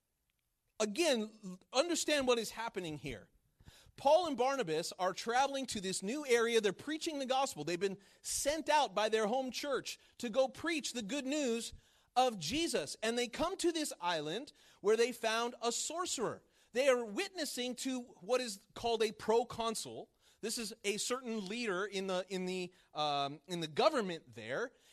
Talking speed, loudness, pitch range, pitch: 165 wpm, -36 LUFS, 195-265 Hz, 230 Hz